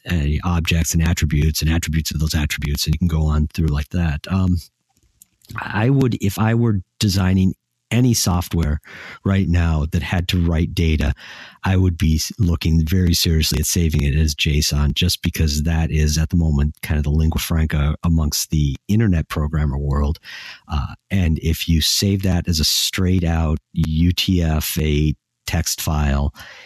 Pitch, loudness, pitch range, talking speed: 80 Hz, -19 LUFS, 75-90 Hz, 165 wpm